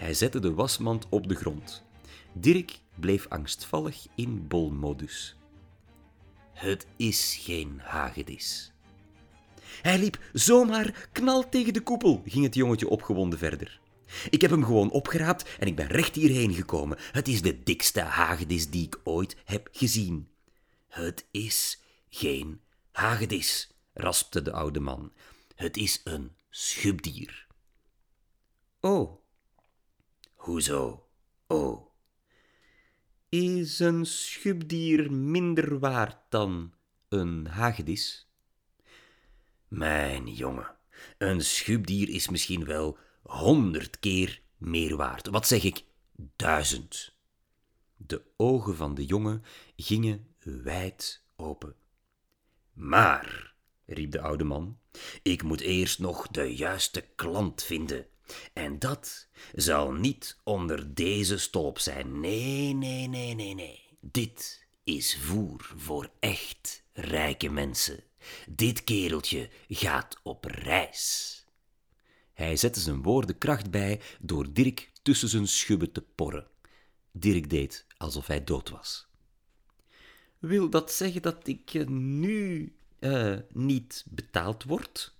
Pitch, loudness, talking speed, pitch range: 100 Hz, -29 LUFS, 115 wpm, 80-130 Hz